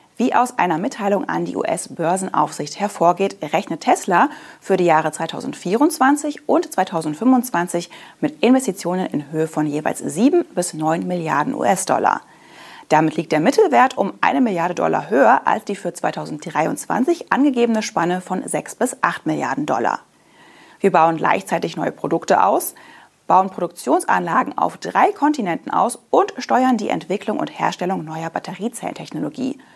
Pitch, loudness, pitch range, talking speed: 190 Hz, -19 LUFS, 170-260 Hz, 135 wpm